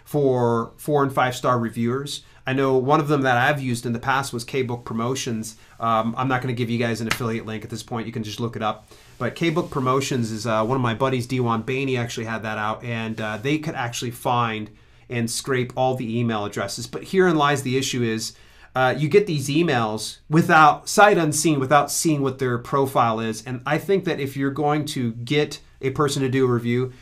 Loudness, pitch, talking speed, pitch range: -22 LUFS, 125 Hz, 225 wpm, 115-140 Hz